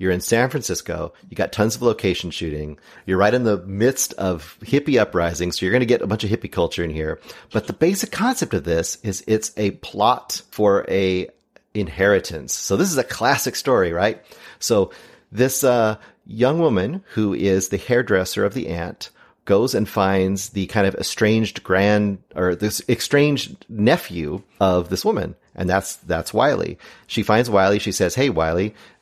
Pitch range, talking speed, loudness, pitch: 95-120 Hz, 180 wpm, -20 LUFS, 100 Hz